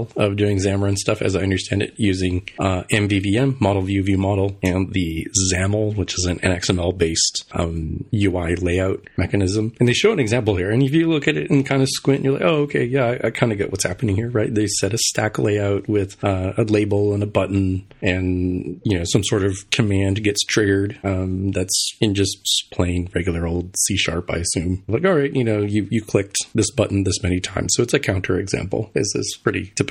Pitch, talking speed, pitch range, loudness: 100 Hz, 220 wpm, 95-110 Hz, -20 LUFS